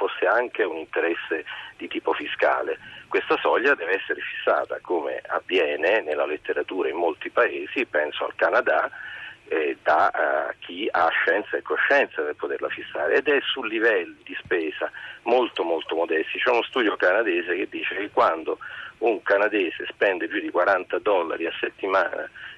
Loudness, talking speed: -24 LUFS, 155 wpm